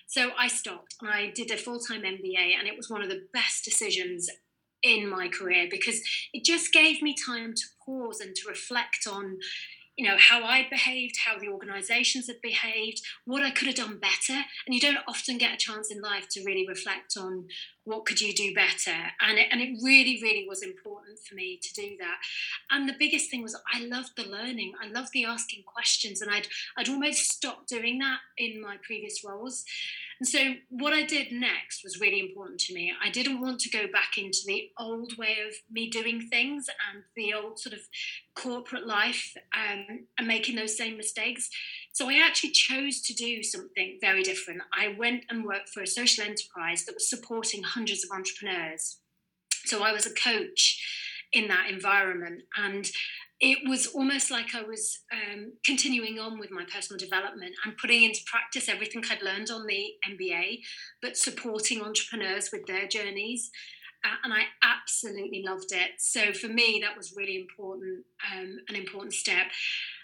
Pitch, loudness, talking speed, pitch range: 230 Hz, -27 LUFS, 190 wpm, 200-260 Hz